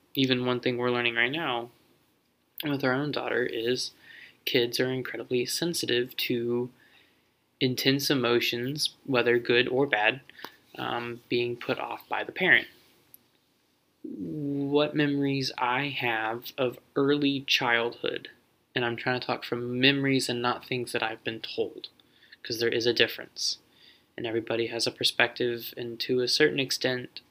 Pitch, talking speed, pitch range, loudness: 125 Hz, 145 wpm, 120-135 Hz, -27 LUFS